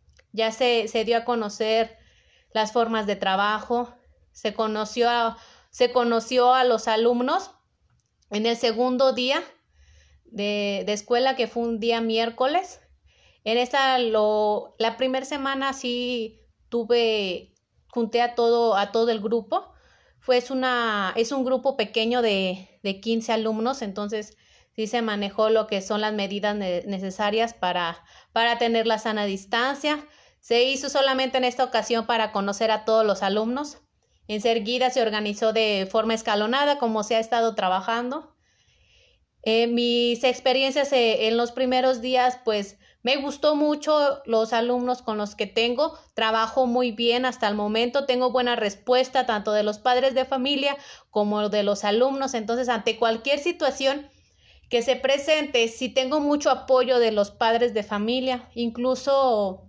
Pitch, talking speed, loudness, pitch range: 235 Hz, 150 wpm, -23 LUFS, 220-255 Hz